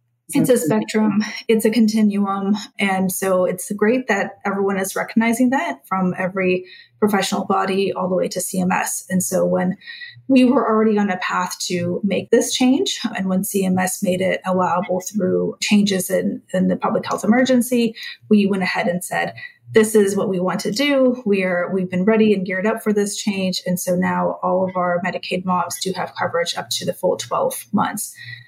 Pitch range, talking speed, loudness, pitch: 180-220 Hz, 190 wpm, -19 LUFS, 190 Hz